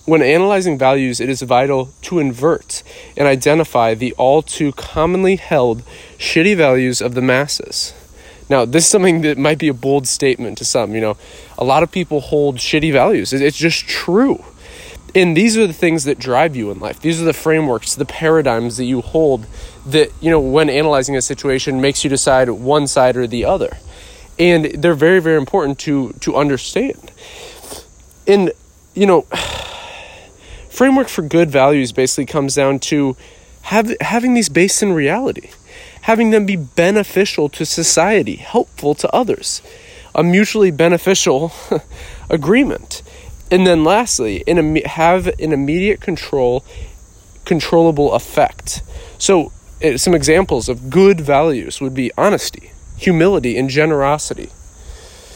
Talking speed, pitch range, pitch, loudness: 150 wpm, 130-175 Hz, 150 Hz, -14 LUFS